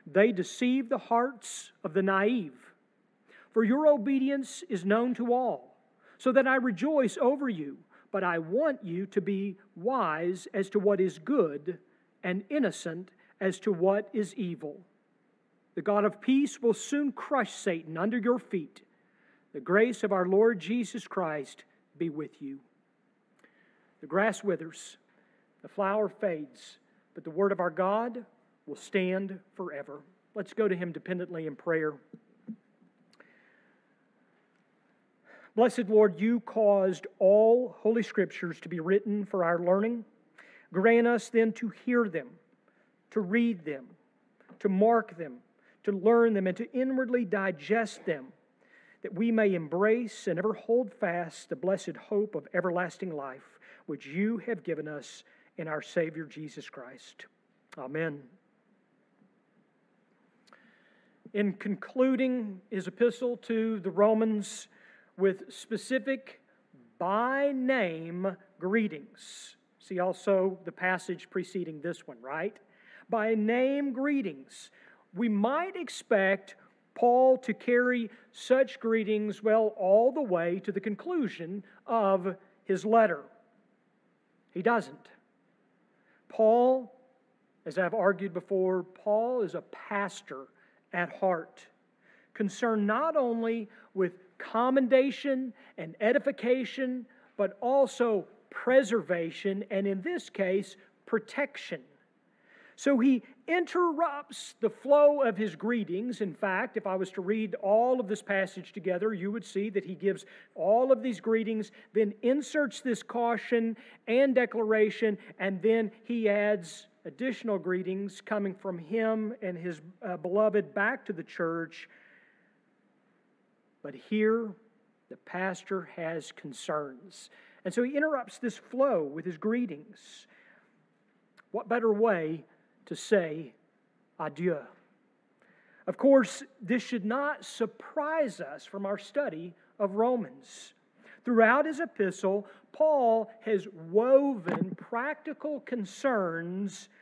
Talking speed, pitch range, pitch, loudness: 125 wpm, 190-240 Hz, 215 Hz, -30 LUFS